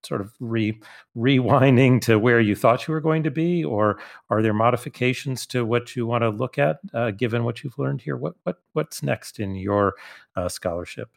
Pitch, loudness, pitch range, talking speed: 120 Hz, -22 LUFS, 110-135 Hz, 205 wpm